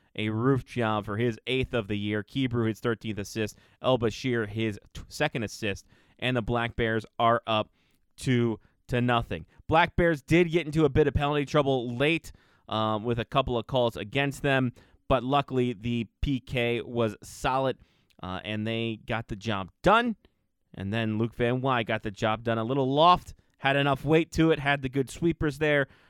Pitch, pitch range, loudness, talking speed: 120 Hz, 110-135 Hz, -27 LUFS, 190 wpm